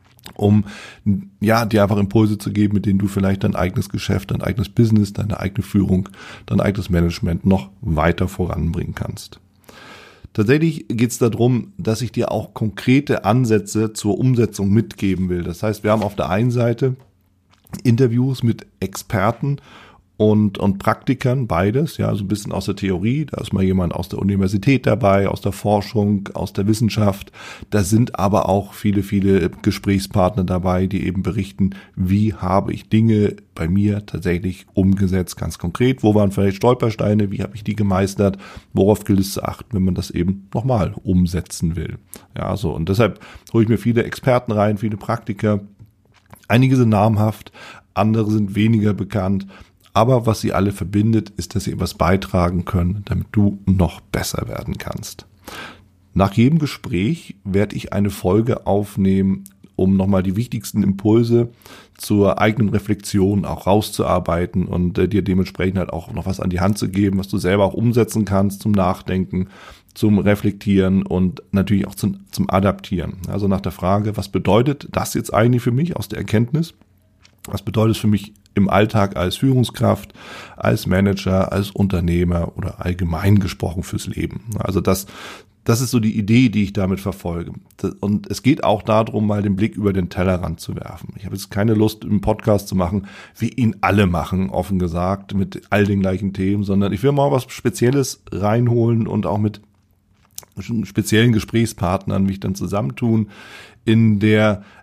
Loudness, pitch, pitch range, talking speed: -19 LUFS, 100 Hz, 95-110 Hz, 170 wpm